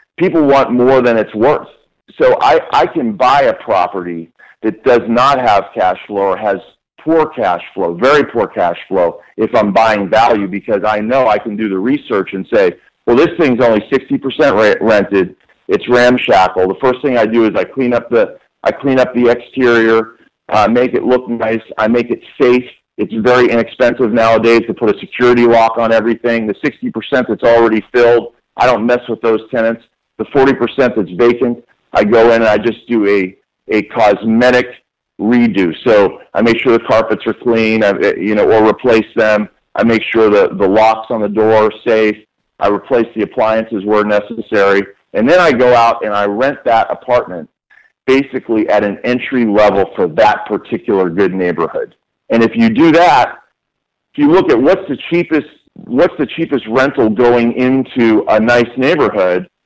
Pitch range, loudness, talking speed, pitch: 110-125 Hz, -12 LUFS, 185 wpm, 115 Hz